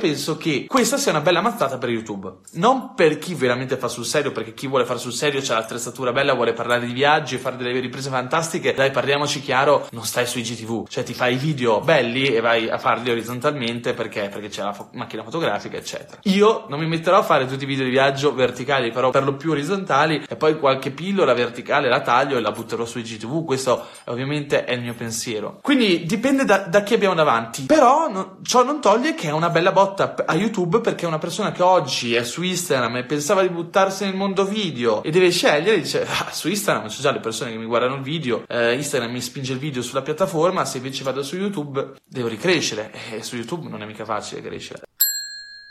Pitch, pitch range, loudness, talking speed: 140 Hz, 120-180 Hz, -21 LUFS, 220 wpm